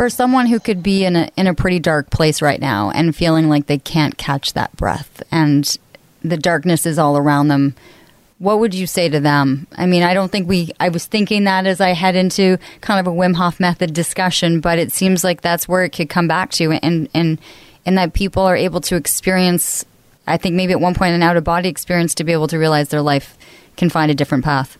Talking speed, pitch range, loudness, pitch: 235 wpm, 155-185 Hz, -16 LUFS, 170 Hz